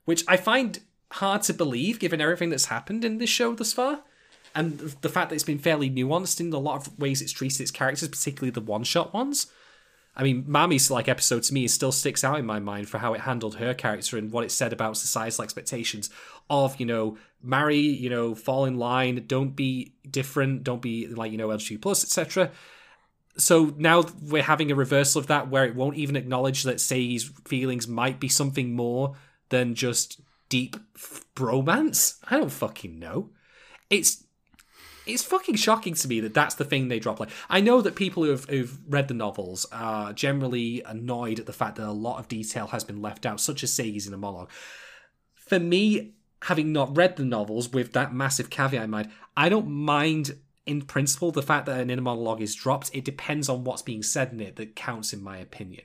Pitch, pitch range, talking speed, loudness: 135 Hz, 120-155 Hz, 210 wpm, -26 LUFS